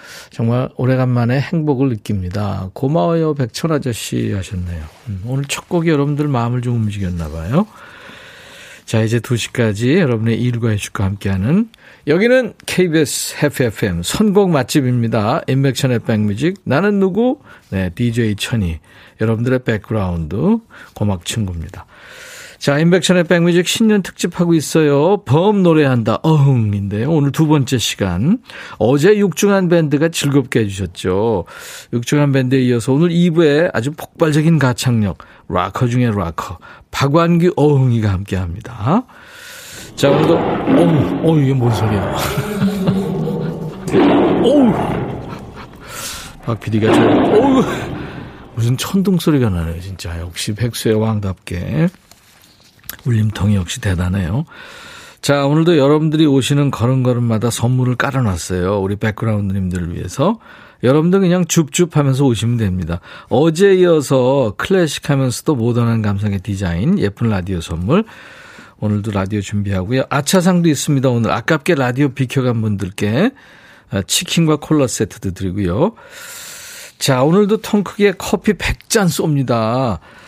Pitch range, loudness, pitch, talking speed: 110-170 Hz, -16 LUFS, 130 Hz, 300 characters per minute